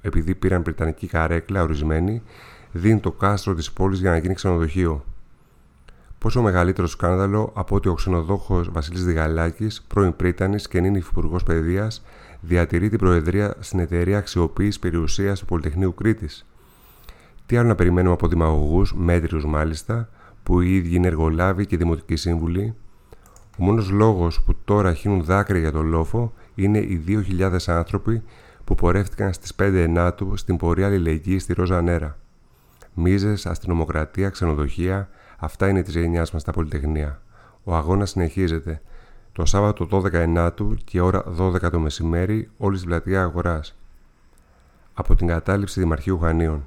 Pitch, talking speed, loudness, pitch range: 90 Hz, 145 wpm, -22 LUFS, 85-100 Hz